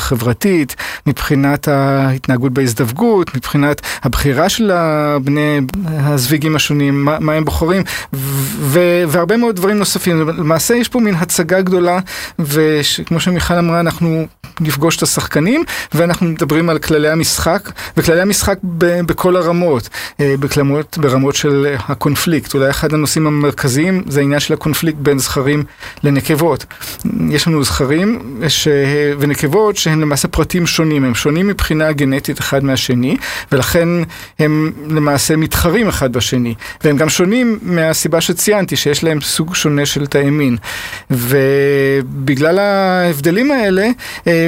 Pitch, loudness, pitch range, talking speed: 155 Hz, -14 LUFS, 145-175 Hz, 125 wpm